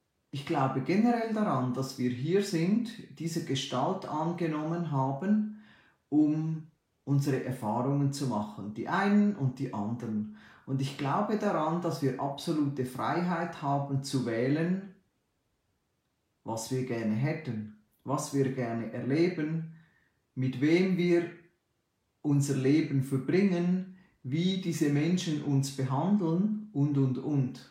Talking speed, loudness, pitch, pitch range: 120 wpm, -30 LUFS, 140 Hz, 130-170 Hz